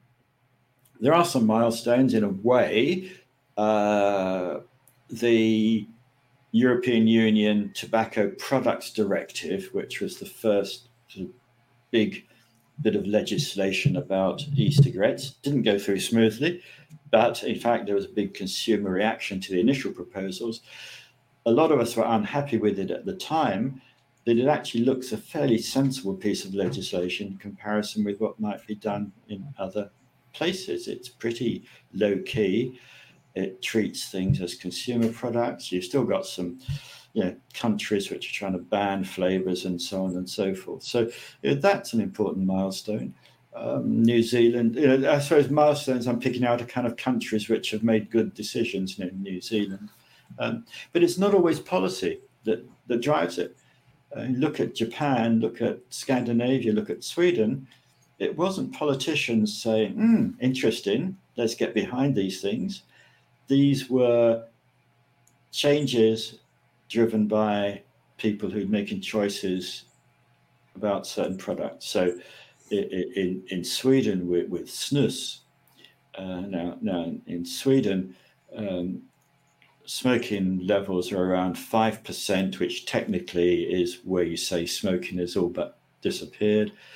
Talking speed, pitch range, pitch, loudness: 140 wpm, 100-130 Hz, 115 Hz, -26 LUFS